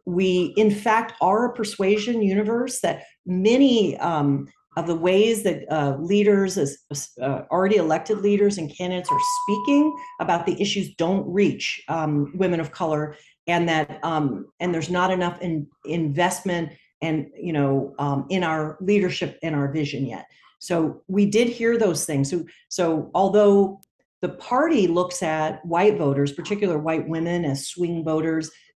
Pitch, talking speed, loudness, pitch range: 175 Hz, 155 wpm, -22 LUFS, 155-205 Hz